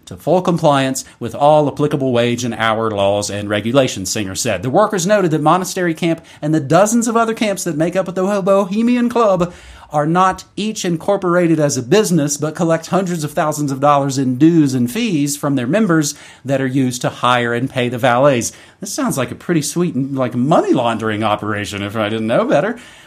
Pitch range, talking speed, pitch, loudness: 125-175 Hz, 205 wpm, 150 Hz, -16 LUFS